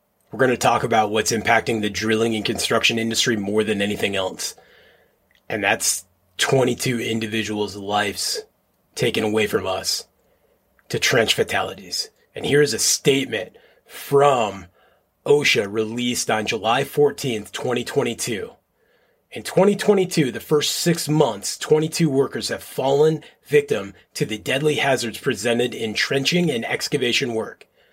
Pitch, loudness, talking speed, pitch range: 135 Hz, -21 LUFS, 130 wpm, 110-170 Hz